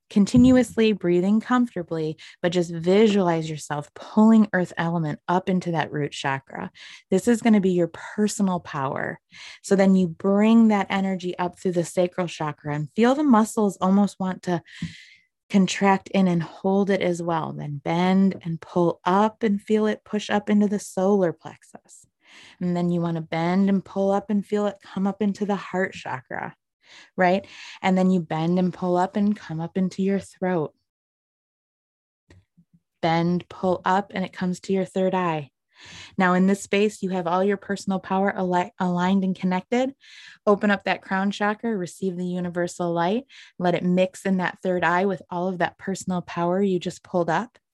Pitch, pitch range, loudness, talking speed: 185 Hz, 175-200 Hz, -23 LUFS, 180 wpm